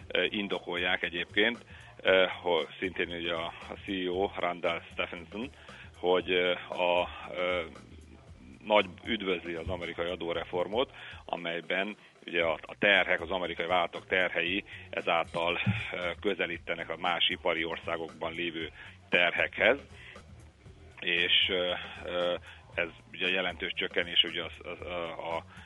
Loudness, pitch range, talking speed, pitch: -30 LUFS, 85-95 Hz, 100 wpm, 90 Hz